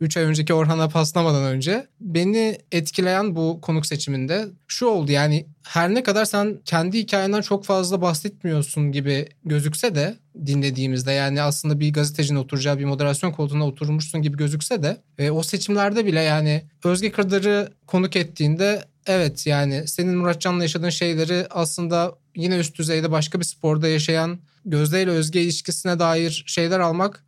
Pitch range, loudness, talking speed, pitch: 150-185 Hz, -22 LUFS, 150 wpm, 165 Hz